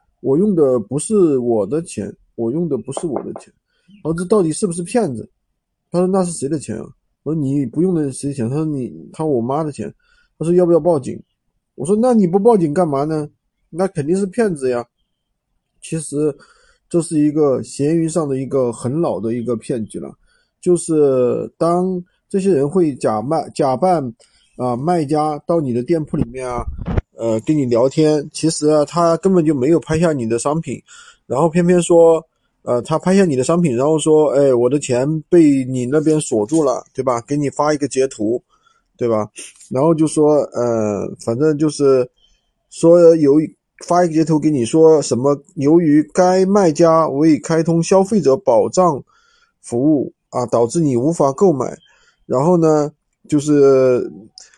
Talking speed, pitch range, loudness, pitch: 250 characters per minute, 135-175 Hz, -16 LUFS, 155 Hz